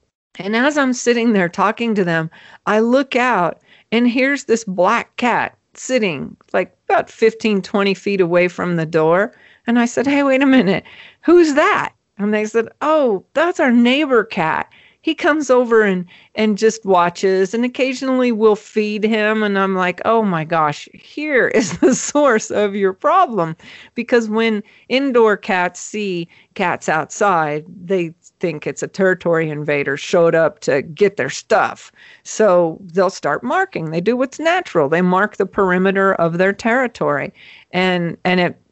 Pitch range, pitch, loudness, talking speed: 180-245 Hz, 210 Hz, -17 LUFS, 165 wpm